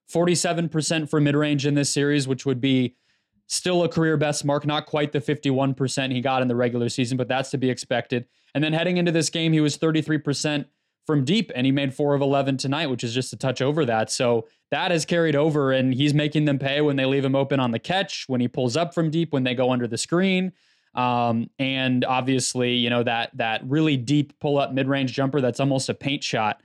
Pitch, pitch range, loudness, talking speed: 140 Hz, 130-150 Hz, -23 LUFS, 225 wpm